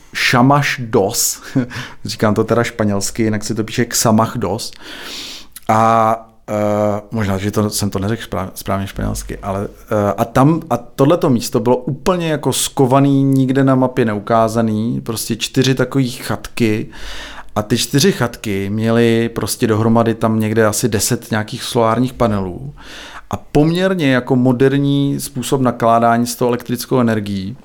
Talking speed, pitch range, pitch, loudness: 140 wpm, 110-130 Hz, 115 Hz, -16 LUFS